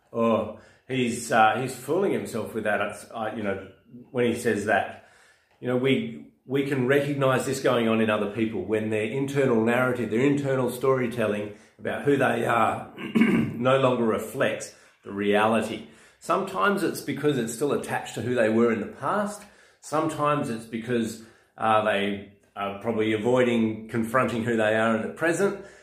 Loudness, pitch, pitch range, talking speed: -25 LUFS, 115 Hz, 110-130 Hz, 165 wpm